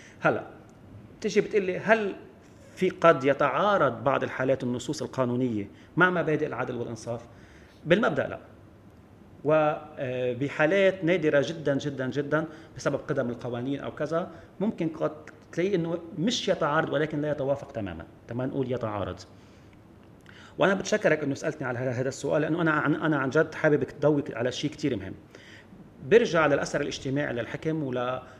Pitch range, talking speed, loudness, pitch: 120-160 Hz, 130 wpm, -27 LUFS, 140 Hz